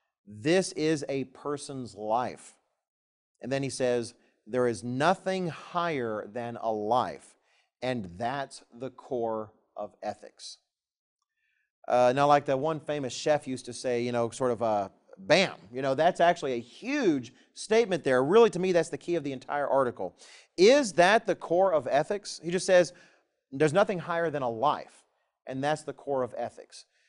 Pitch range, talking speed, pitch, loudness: 125-175 Hz, 175 wpm, 140 Hz, -28 LUFS